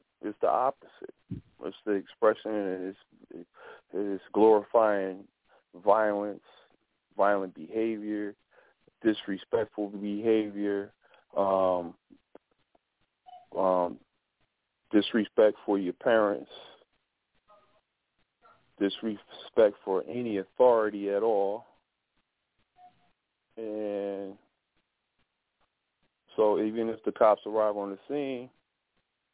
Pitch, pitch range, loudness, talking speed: 105 Hz, 100-110 Hz, -29 LUFS, 75 wpm